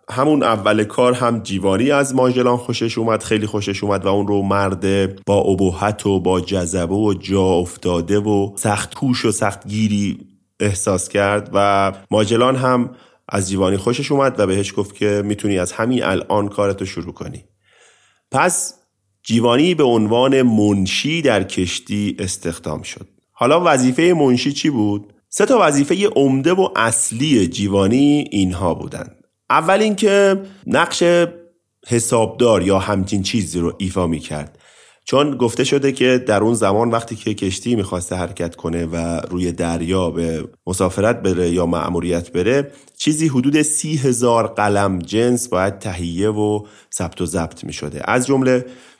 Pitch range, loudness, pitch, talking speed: 95-125 Hz, -17 LUFS, 105 Hz, 150 wpm